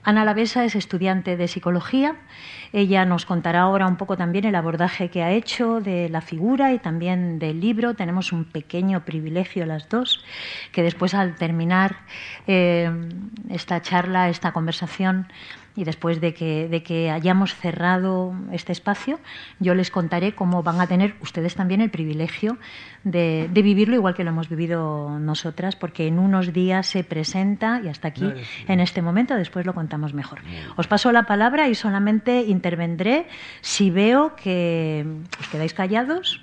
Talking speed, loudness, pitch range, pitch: 165 wpm, -22 LUFS, 170-205 Hz, 180 Hz